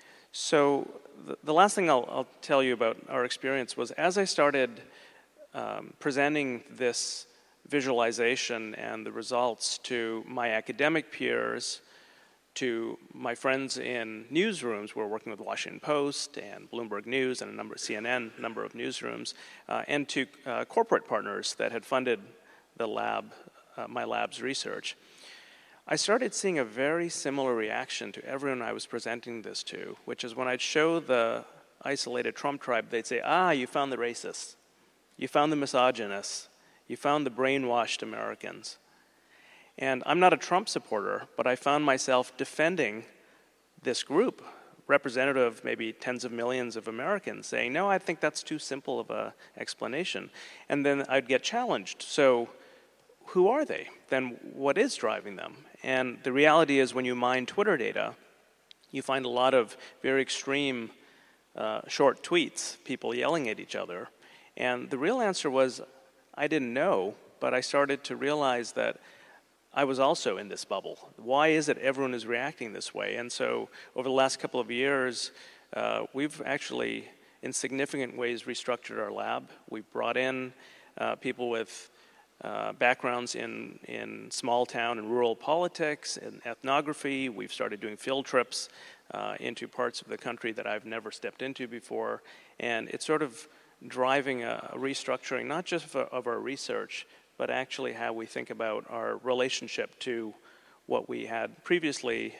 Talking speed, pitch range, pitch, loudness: 165 wpm, 120-145 Hz, 130 Hz, -30 LUFS